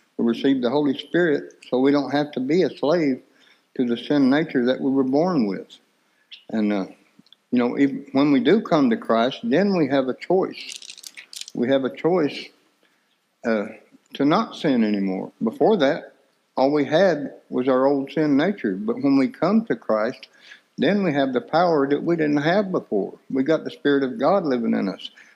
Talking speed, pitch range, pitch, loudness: 195 wpm, 130-180 Hz, 140 Hz, -21 LUFS